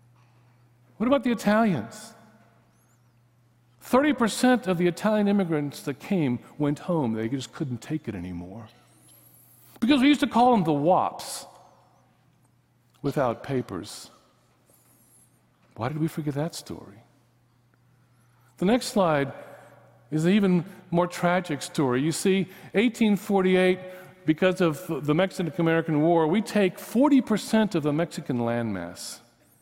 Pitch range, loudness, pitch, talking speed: 125-195 Hz, -25 LUFS, 160 Hz, 120 wpm